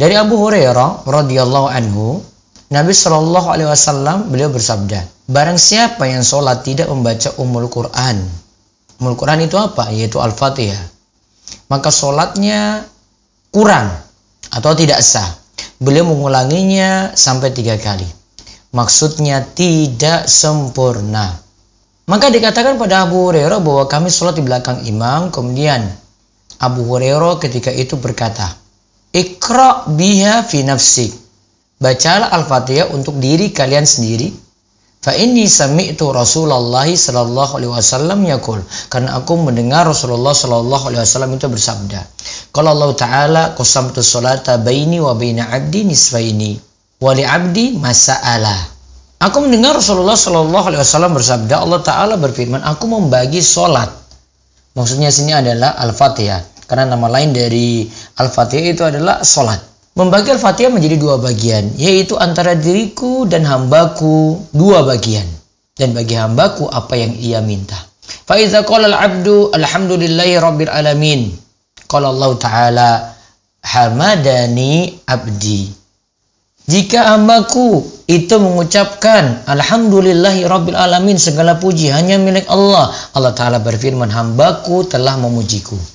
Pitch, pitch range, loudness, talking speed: 135 Hz, 115-170 Hz, -11 LUFS, 115 wpm